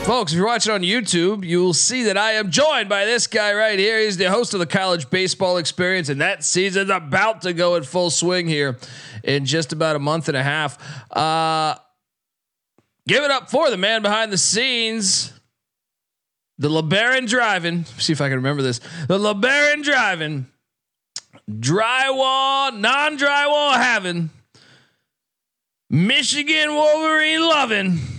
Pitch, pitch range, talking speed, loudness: 185 Hz, 155-230 Hz, 155 wpm, -18 LUFS